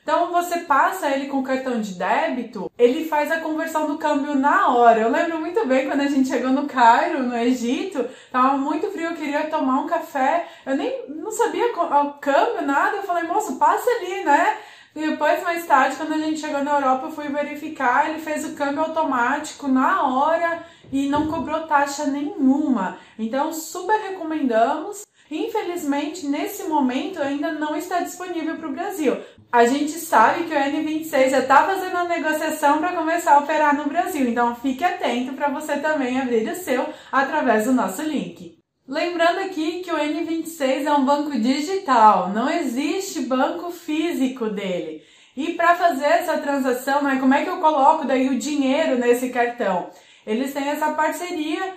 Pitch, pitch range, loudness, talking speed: 295 Hz, 265-325 Hz, -21 LUFS, 175 wpm